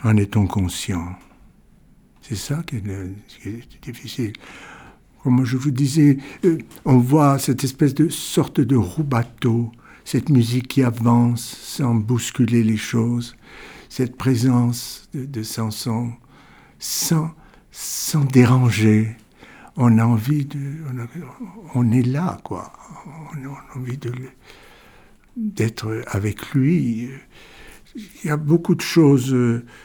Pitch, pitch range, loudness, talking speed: 125 Hz, 115-145 Hz, -20 LUFS, 125 wpm